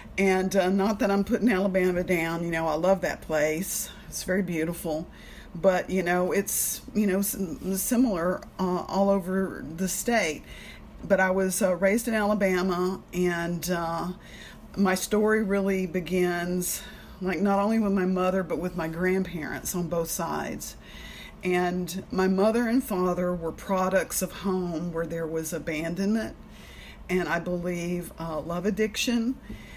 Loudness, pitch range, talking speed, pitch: -27 LUFS, 175-195 Hz, 150 wpm, 185 Hz